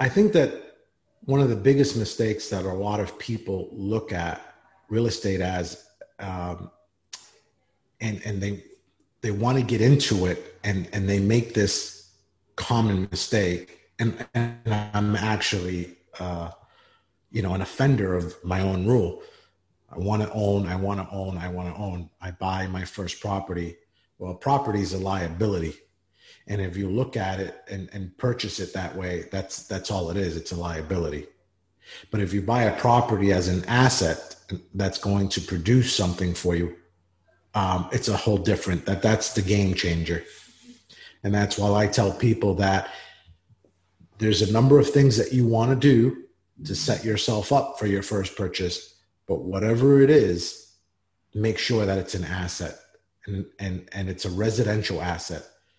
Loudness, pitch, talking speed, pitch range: -25 LUFS, 100 Hz, 165 wpm, 90-110 Hz